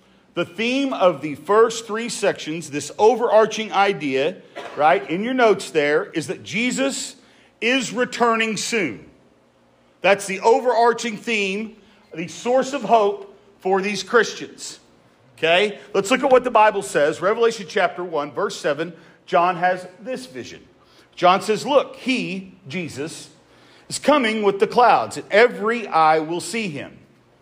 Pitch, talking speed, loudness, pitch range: 200 Hz, 140 wpm, -20 LUFS, 170-230 Hz